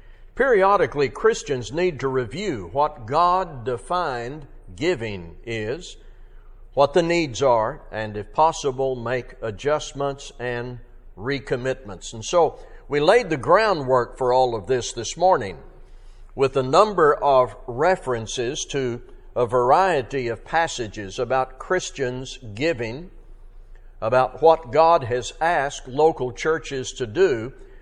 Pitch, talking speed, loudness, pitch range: 130 Hz, 120 wpm, -22 LUFS, 120-160 Hz